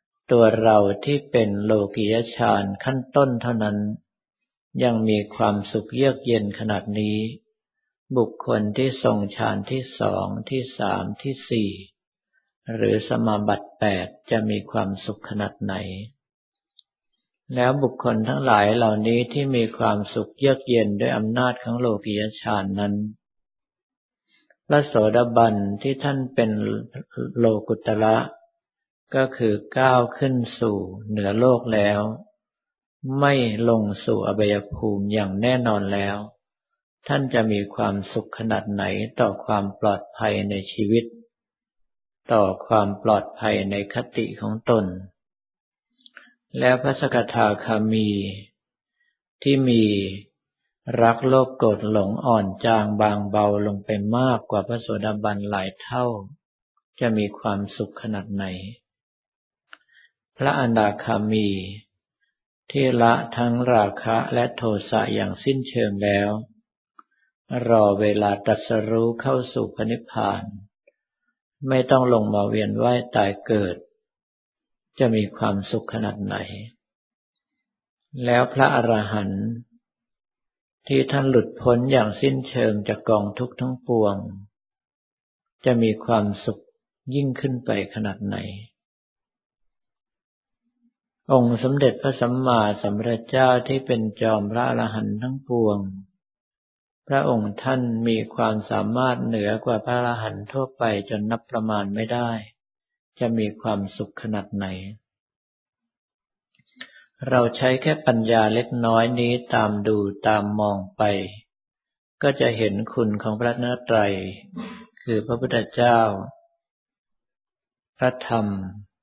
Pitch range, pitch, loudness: 105-125 Hz, 115 Hz, -22 LUFS